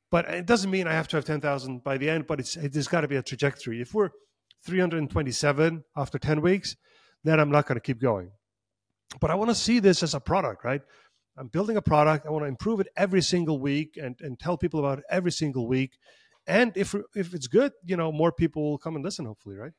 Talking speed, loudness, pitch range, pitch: 240 wpm, -27 LUFS, 140-175 Hz, 155 Hz